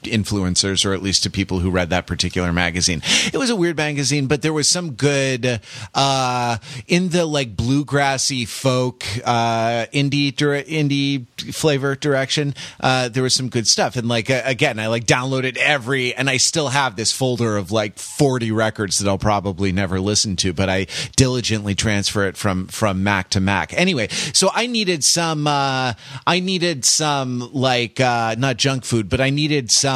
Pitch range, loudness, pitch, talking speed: 105-140 Hz, -18 LUFS, 130 Hz, 180 wpm